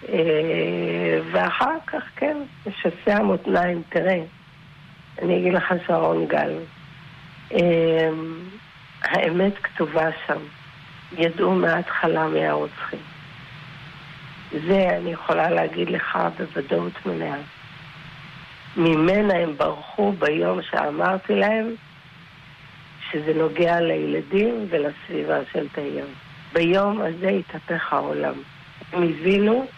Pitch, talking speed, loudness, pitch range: 160 Hz, 90 wpm, -22 LUFS, 150-175 Hz